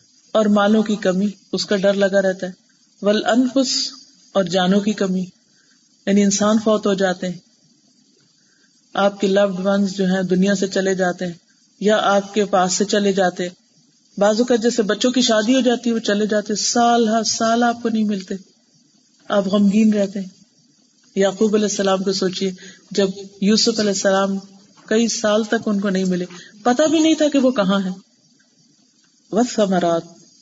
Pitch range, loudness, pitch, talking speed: 195-230 Hz, -18 LUFS, 205 Hz, 175 wpm